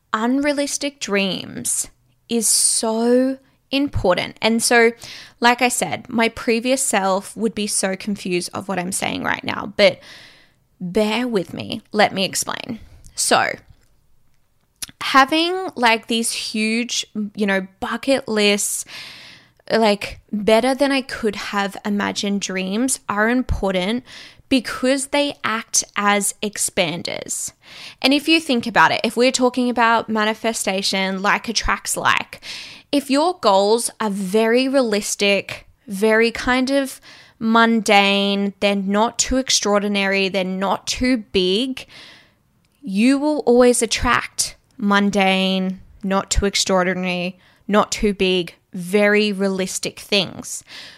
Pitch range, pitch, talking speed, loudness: 200-250 Hz, 220 Hz, 120 wpm, -19 LUFS